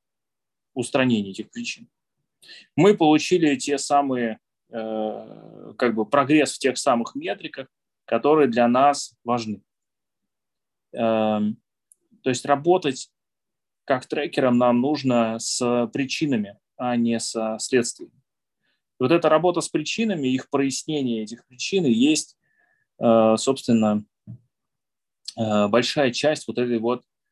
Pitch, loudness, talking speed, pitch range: 125 Hz, -22 LUFS, 115 wpm, 115-150 Hz